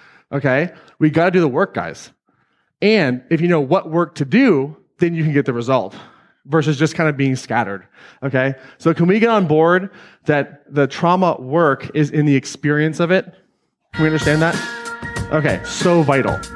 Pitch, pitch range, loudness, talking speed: 155 Hz, 140-175 Hz, -17 LUFS, 185 wpm